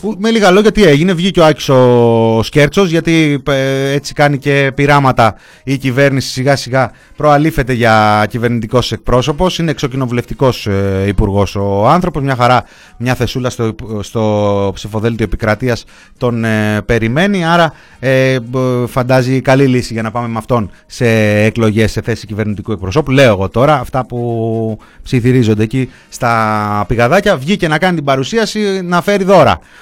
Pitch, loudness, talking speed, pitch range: 125 Hz, -12 LUFS, 150 wpm, 110-145 Hz